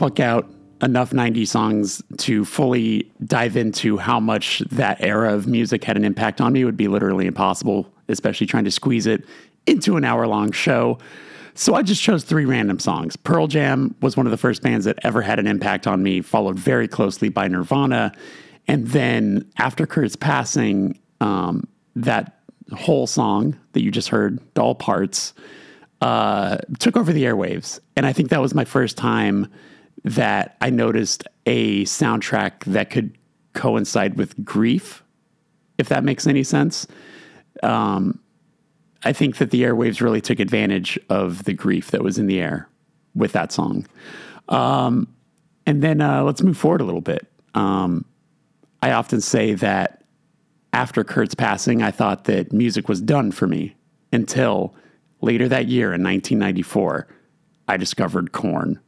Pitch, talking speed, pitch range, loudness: 115 Hz, 160 wpm, 100-135 Hz, -20 LUFS